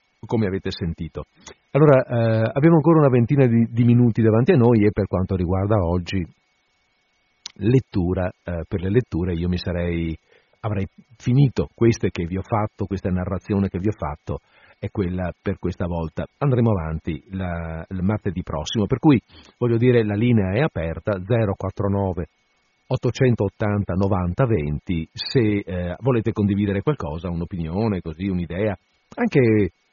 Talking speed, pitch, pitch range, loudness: 145 wpm, 100 Hz, 90-115 Hz, -21 LUFS